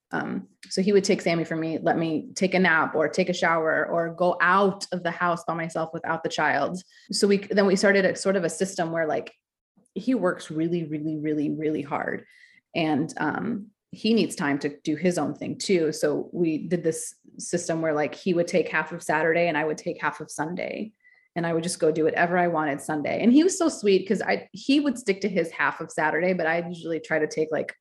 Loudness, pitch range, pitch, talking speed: -25 LUFS, 160-195 Hz, 170 Hz, 235 wpm